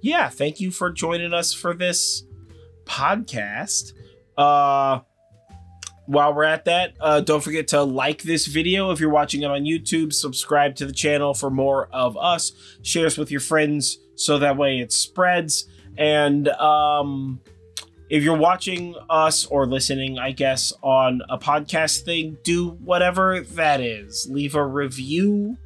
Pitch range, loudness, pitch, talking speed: 130-165 Hz, -21 LUFS, 145 Hz, 155 wpm